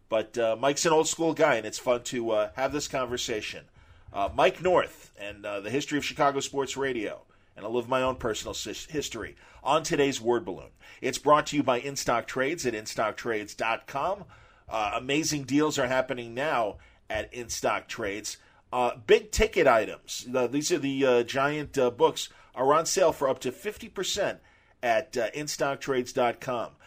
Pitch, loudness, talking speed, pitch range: 135 Hz, -28 LUFS, 170 wpm, 125-150 Hz